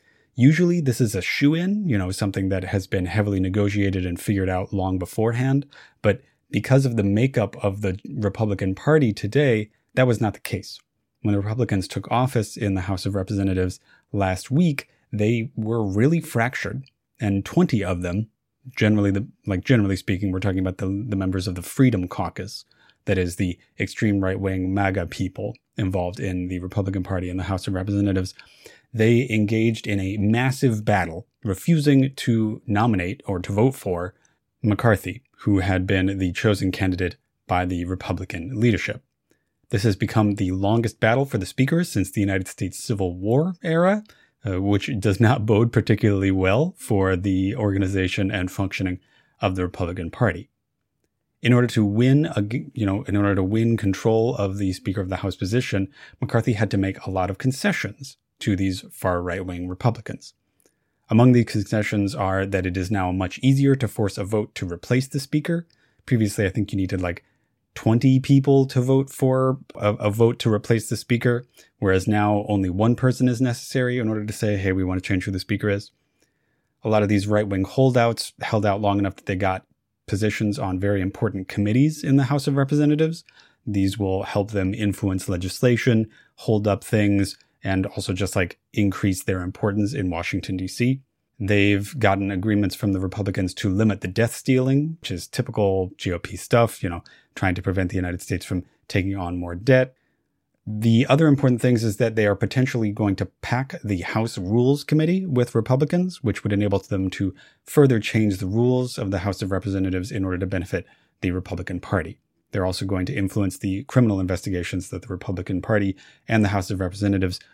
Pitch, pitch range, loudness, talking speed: 105 Hz, 95-120 Hz, -23 LUFS, 185 wpm